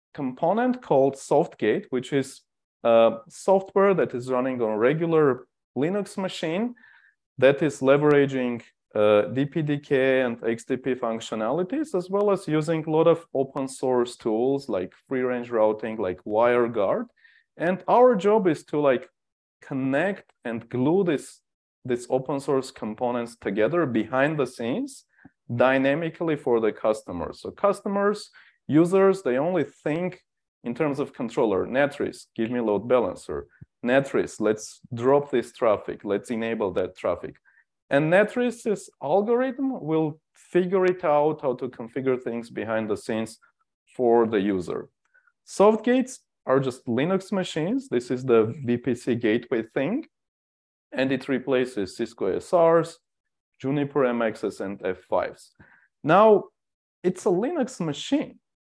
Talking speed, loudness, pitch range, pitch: 130 wpm, -24 LUFS, 120-185 Hz, 140 Hz